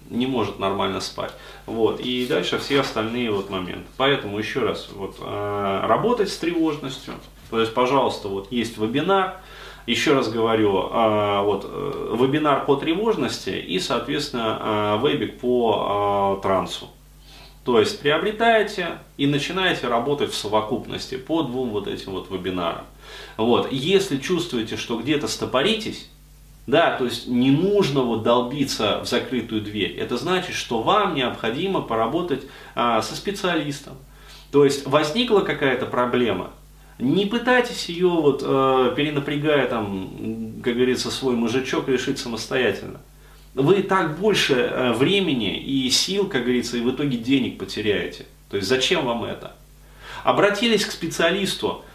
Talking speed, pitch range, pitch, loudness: 135 wpm, 115-160 Hz, 130 Hz, -22 LUFS